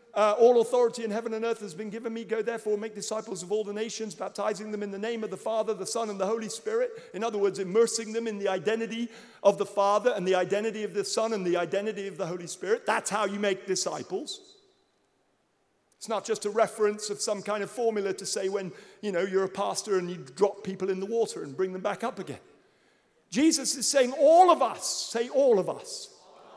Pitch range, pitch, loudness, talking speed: 200-230 Hz, 215 Hz, -28 LUFS, 235 wpm